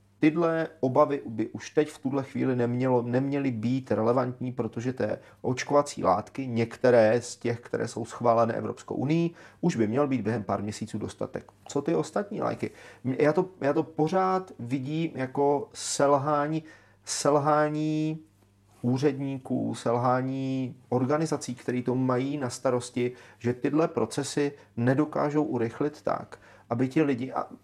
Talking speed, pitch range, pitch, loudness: 135 wpm, 120-150 Hz, 130 Hz, -28 LUFS